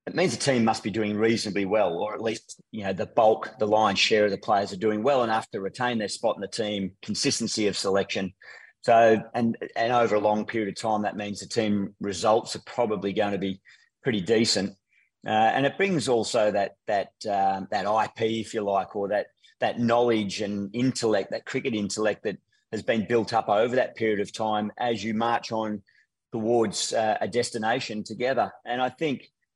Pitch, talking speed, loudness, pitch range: 110 Hz, 205 wpm, -26 LUFS, 105-115 Hz